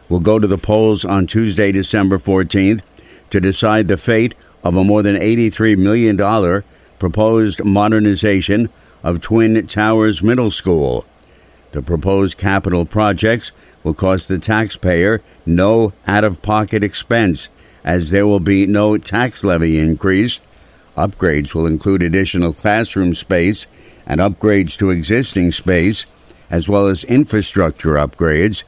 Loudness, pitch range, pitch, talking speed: -15 LUFS, 90-110 Hz, 100 Hz, 130 wpm